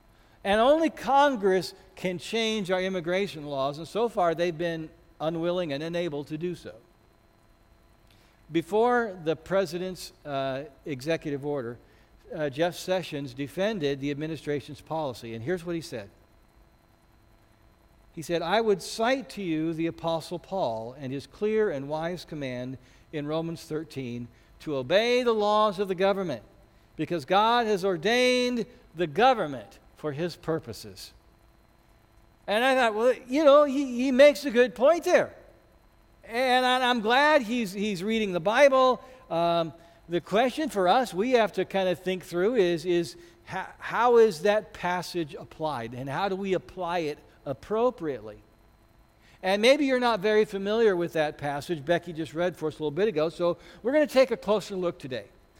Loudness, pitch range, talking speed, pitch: -26 LUFS, 145-215 Hz, 160 wpm, 175 Hz